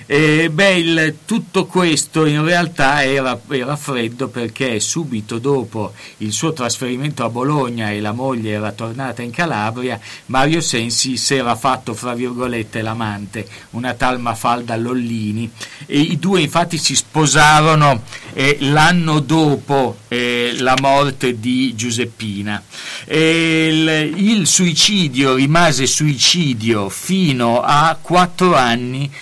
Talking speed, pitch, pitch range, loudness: 125 wpm, 130 Hz, 120-155 Hz, -15 LUFS